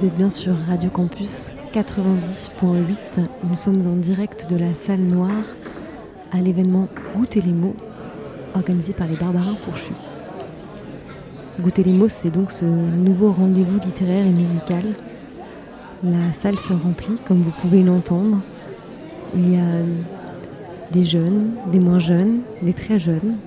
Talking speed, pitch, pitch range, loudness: 140 wpm, 185 Hz, 175-195 Hz, -19 LUFS